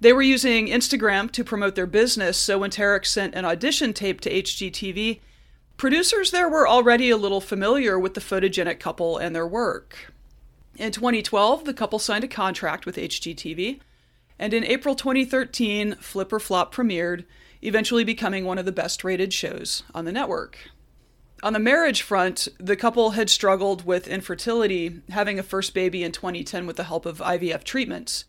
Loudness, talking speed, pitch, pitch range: -23 LUFS, 165 wpm, 200 Hz, 185-235 Hz